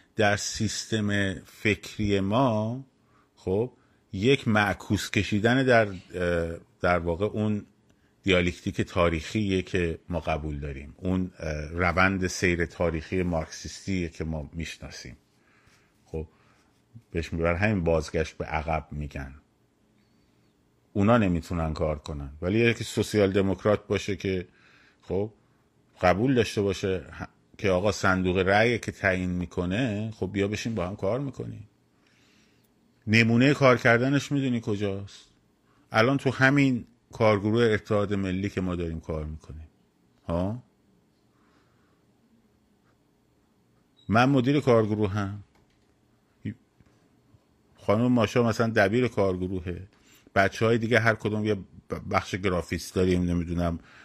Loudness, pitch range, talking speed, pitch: -26 LUFS, 85-110 Hz, 110 wpm, 100 Hz